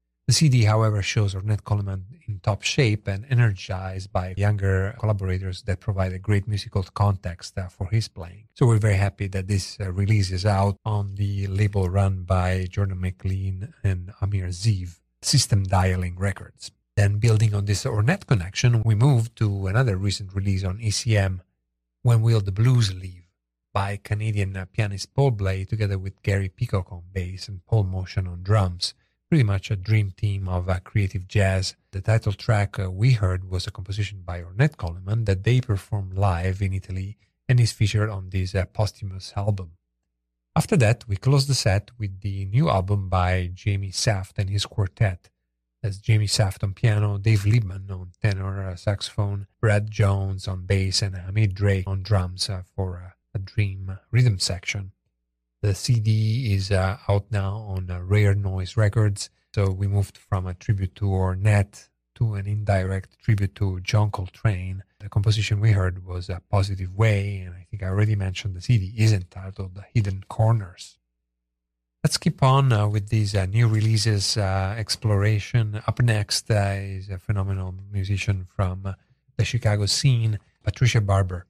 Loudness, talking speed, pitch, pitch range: -24 LUFS, 165 wpm, 100 Hz, 95-110 Hz